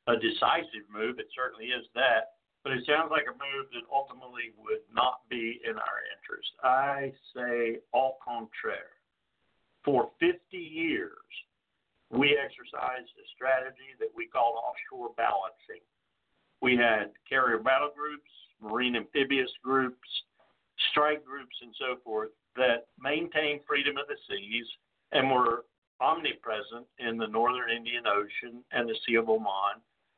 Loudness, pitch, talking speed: -30 LUFS, 135 Hz, 135 wpm